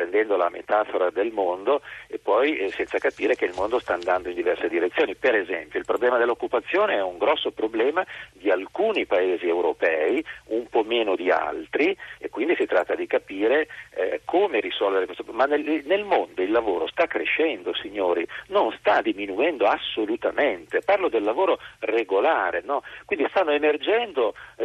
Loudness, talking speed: -24 LUFS, 155 wpm